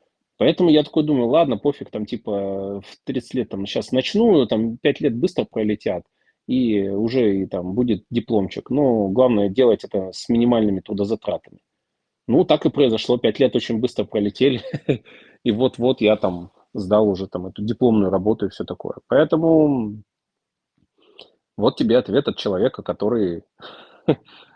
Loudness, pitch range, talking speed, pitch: -20 LUFS, 100-130 Hz, 150 wpm, 110 Hz